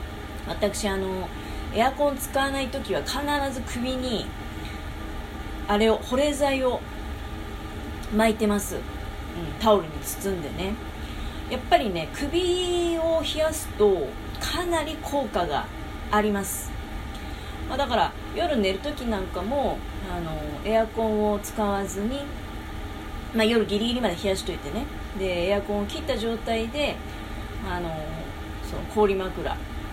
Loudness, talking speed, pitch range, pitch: -27 LUFS, 235 characters per minute, 185-275 Hz, 215 Hz